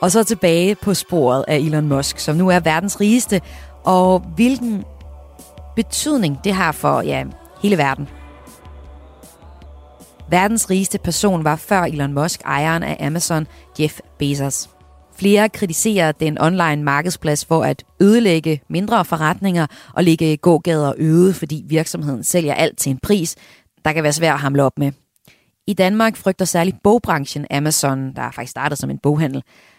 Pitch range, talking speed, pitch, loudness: 140-185 Hz, 155 wpm, 160 Hz, -17 LUFS